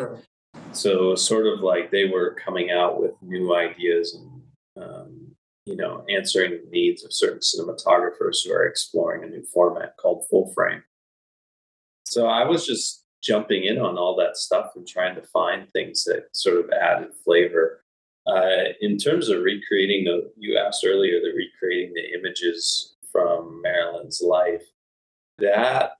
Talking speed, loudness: 155 wpm, -22 LUFS